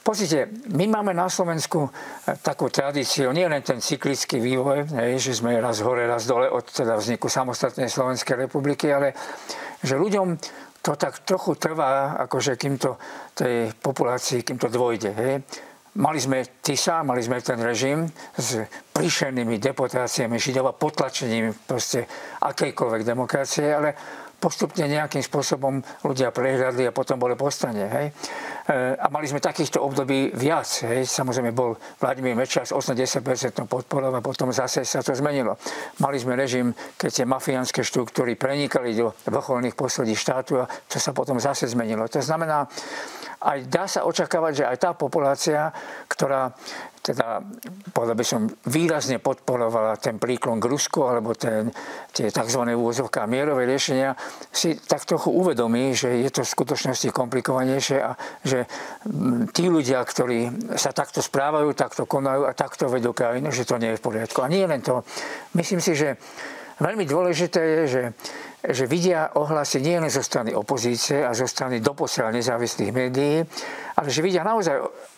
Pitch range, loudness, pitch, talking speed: 125-150 Hz, -24 LUFS, 135 Hz, 150 wpm